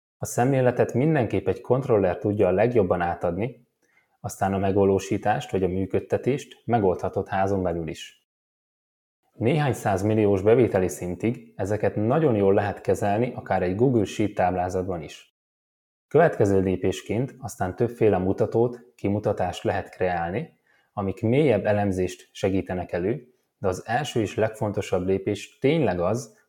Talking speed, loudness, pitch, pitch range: 125 wpm, -24 LUFS, 100 Hz, 95-115 Hz